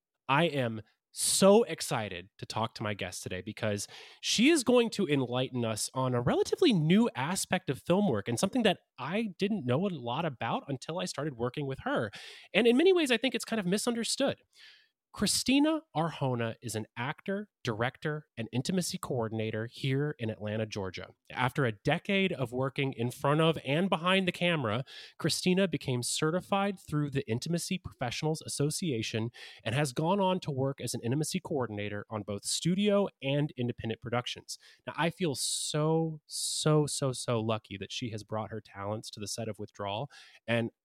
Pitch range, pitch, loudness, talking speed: 115-185 Hz, 140 Hz, -31 LUFS, 175 wpm